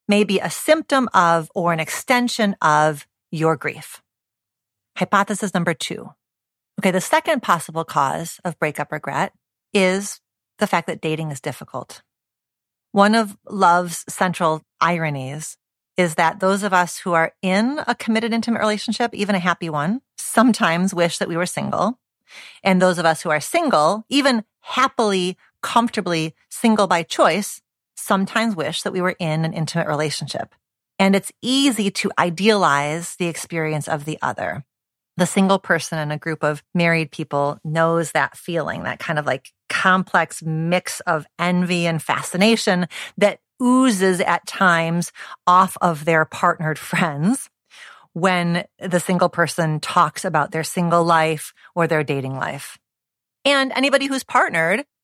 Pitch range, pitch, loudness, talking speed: 155-205 Hz, 175 Hz, -20 LUFS, 150 wpm